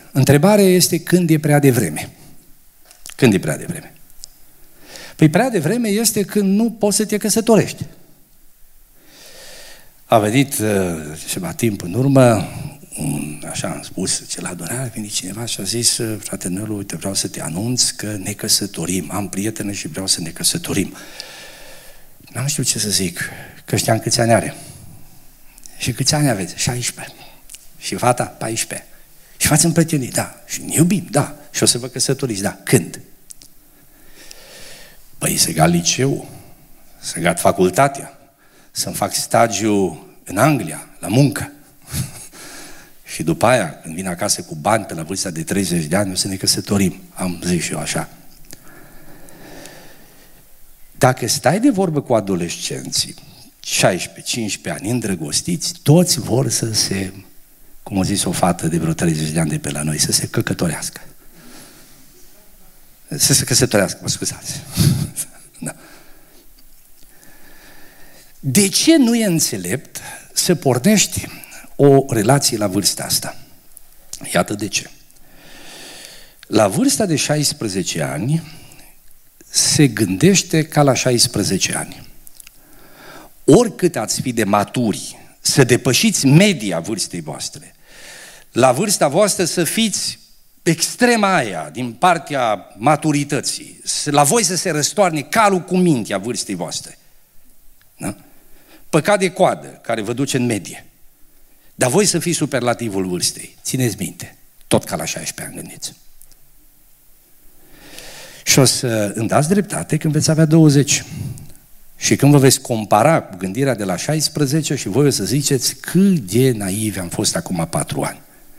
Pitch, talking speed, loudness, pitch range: 135 Hz, 140 wpm, -17 LUFS, 105-160 Hz